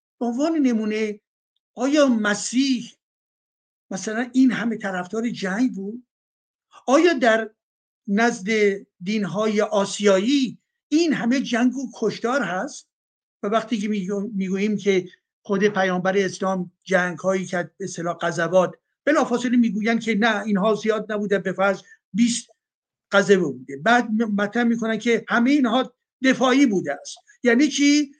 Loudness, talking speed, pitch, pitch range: -22 LUFS, 130 wpm, 220 Hz, 195-245 Hz